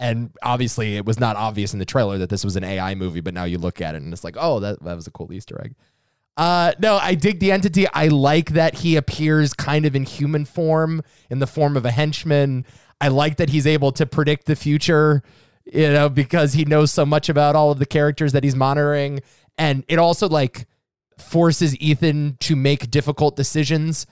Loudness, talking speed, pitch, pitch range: -19 LUFS, 220 wpm, 145 Hz, 125-155 Hz